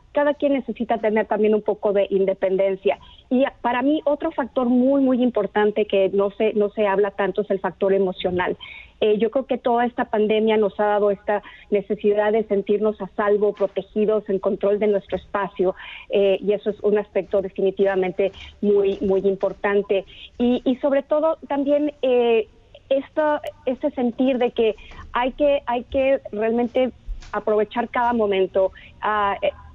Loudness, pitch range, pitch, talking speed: -21 LUFS, 200-250 Hz, 215 Hz, 165 wpm